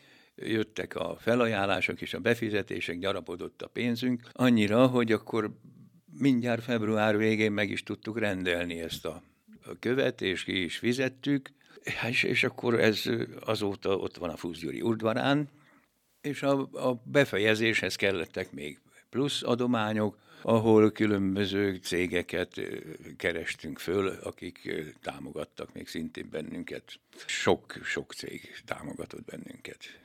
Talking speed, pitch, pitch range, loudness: 115 wpm, 110 Hz, 105-125 Hz, -29 LUFS